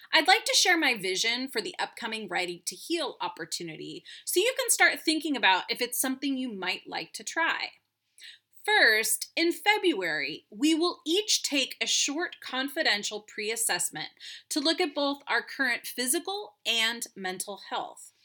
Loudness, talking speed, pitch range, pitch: -27 LUFS, 160 wpm, 225-350 Hz, 290 Hz